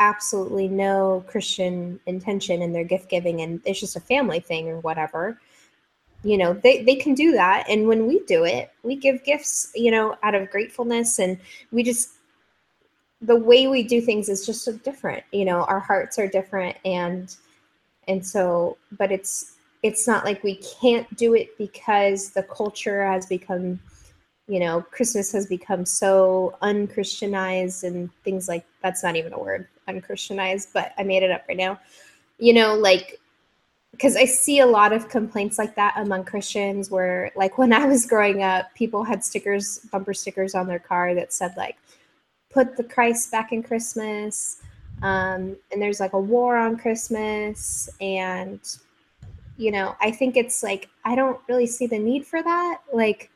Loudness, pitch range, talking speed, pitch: -22 LUFS, 190-235 Hz, 175 wpm, 205 Hz